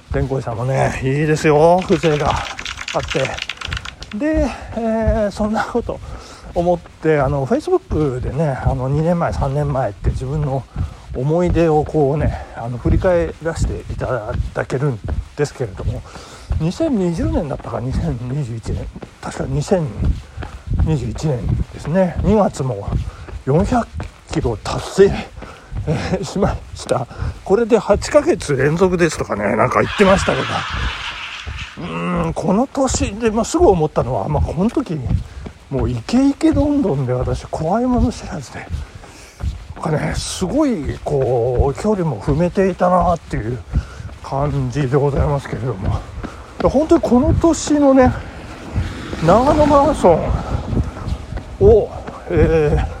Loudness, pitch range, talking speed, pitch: -18 LUFS, 125-205 Hz, 240 characters per minute, 150 Hz